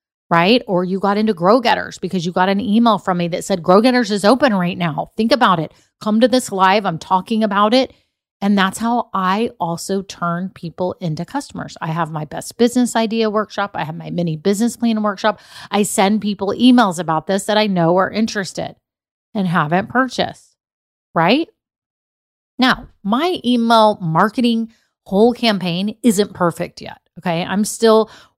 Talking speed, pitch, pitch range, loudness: 175 wpm, 205 Hz, 180-225 Hz, -17 LUFS